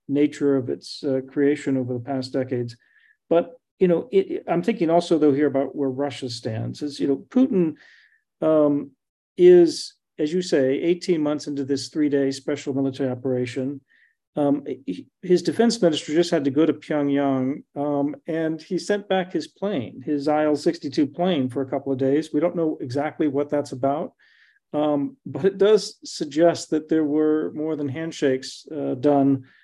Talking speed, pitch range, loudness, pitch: 170 wpm, 140-175 Hz, -23 LUFS, 150 Hz